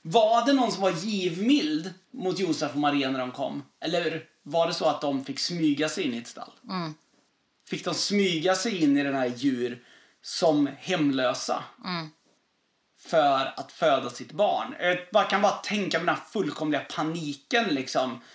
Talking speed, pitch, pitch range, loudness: 170 wpm, 165 Hz, 145-195 Hz, -27 LUFS